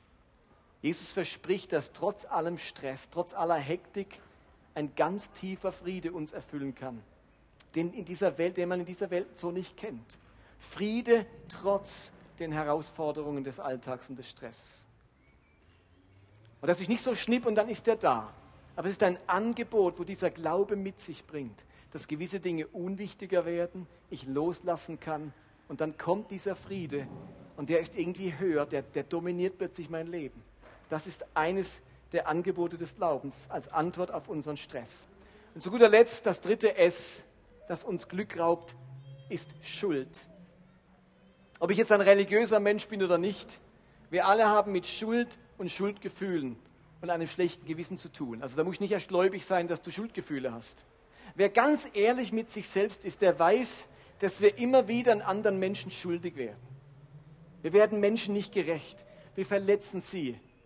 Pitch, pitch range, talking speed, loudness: 175 Hz, 150-200 Hz, 165 wpm, -31 LUFS